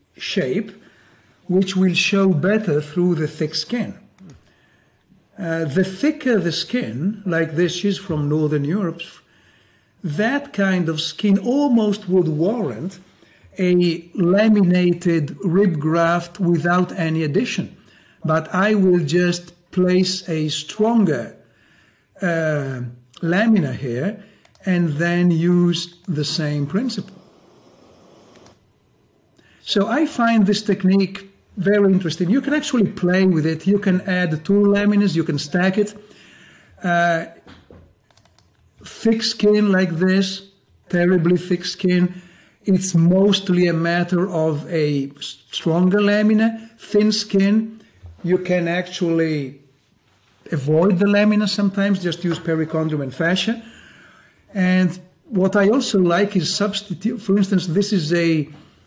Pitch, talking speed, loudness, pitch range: 180 Hz, 115 wpm, -19 LUFS, 165-200 Hz